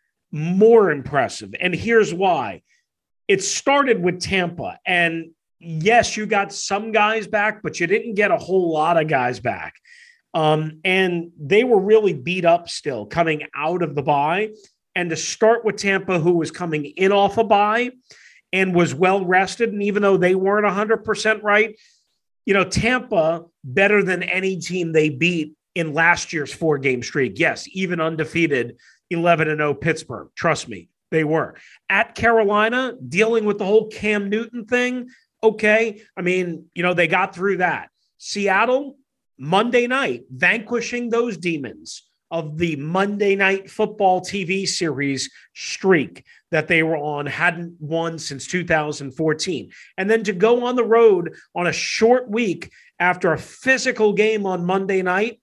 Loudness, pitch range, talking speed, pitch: -19 LUFS, 165-215 Hz, 160 wpm, 190 Hz